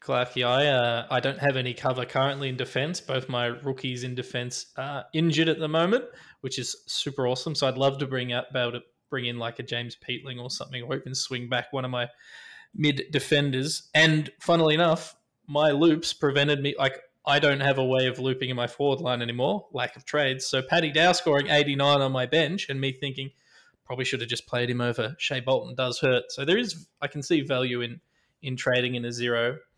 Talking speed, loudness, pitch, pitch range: 225 wpm, -26 LUFS, 130 Hz, 125-145 Hz